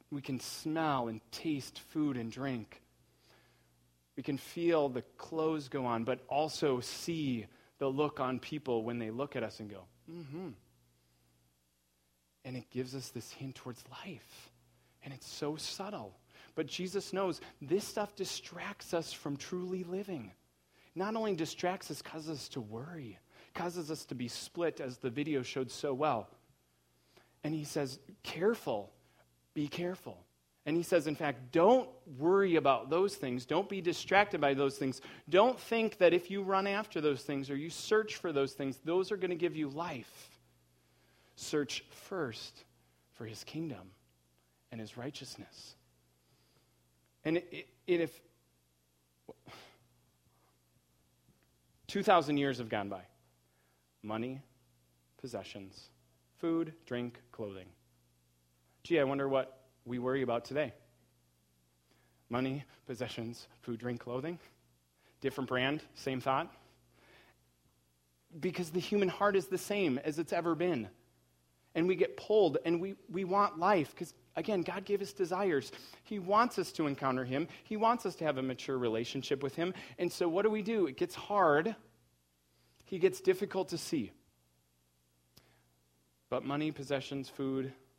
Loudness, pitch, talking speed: -35 LUFS, 135 Hz, 150 wpm